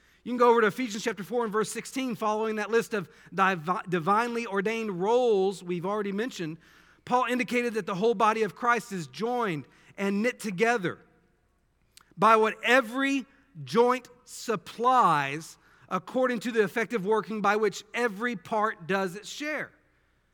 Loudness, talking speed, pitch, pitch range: -27 LUFS, 155 wpm, 220 Hz, 195-240 Hz